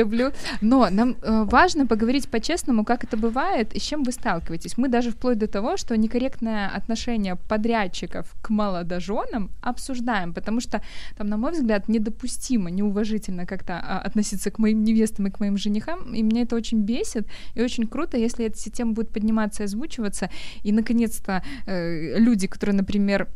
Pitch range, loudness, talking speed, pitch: 205-240 Hz, -24 LUFS, 170 wpm, 220 Hz